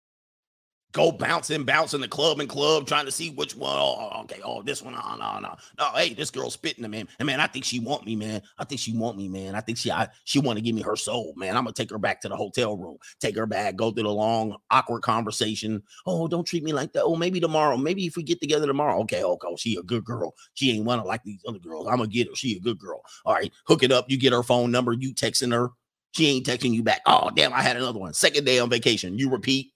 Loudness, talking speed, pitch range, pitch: -25 LUFS, 280 wpm, 115-150 Hz, 125 Hz